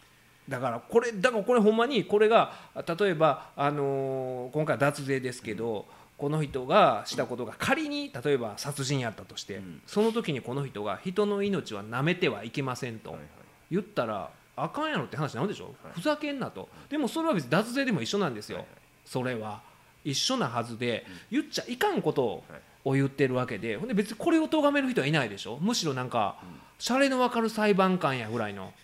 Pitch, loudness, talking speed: 155 Hz, -29 LUFS, 360 characters per minute